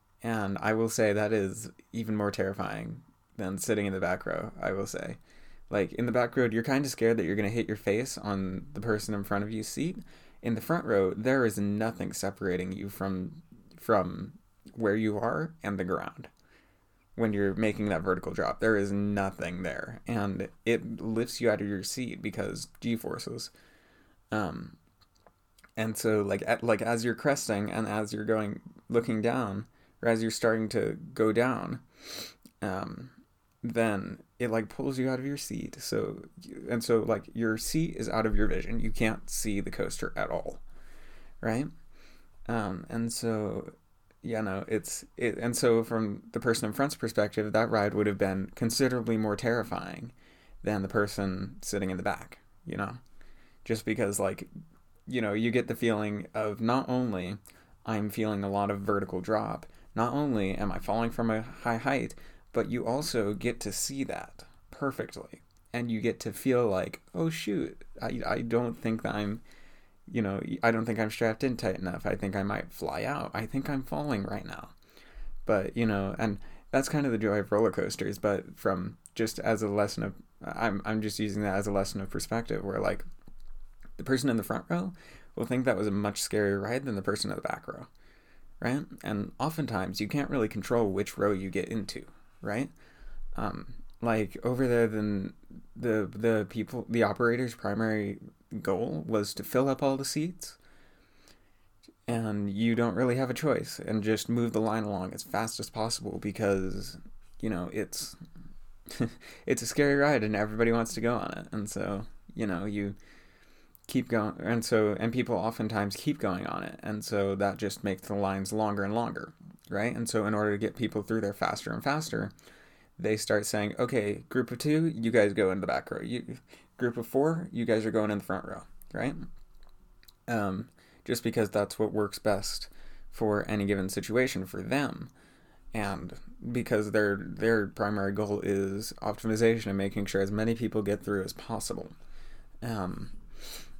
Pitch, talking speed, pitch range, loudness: 110 Hz, 190 wpm, 100-115 Hz, -31 LUFS